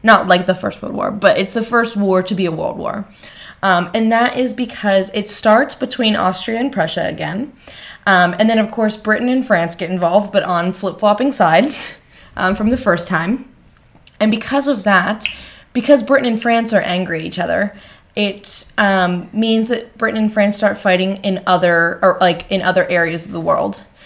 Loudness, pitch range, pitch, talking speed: -16 LUFS, 185-225 Hz, 205 Hz, 200 wpm